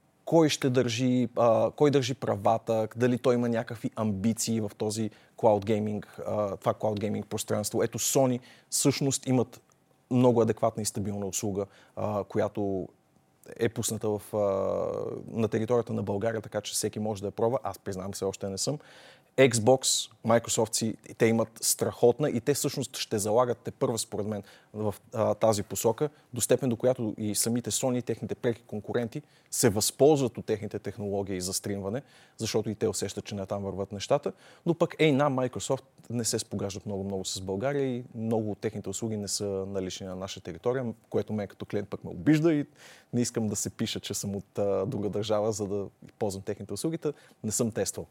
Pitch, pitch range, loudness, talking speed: 110 Hz, 100-125 Hz, -29 LUFS, 180 wpm